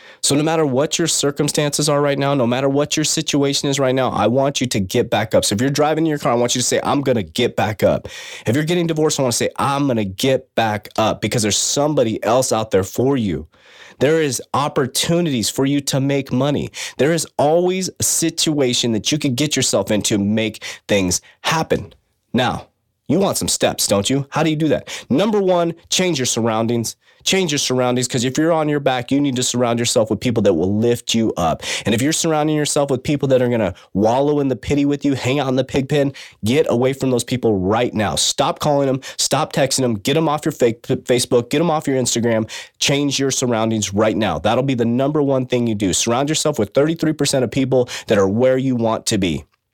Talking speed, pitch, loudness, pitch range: 235 wpm, 135 Hz, -18 LUFS, 120-150 Hz